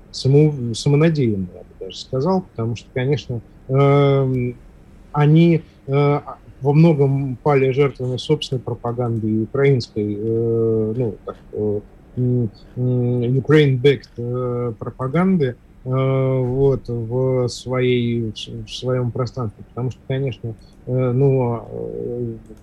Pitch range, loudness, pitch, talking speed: 115-135 Hz, -19 LUFS, 125 Hz, 80 wpm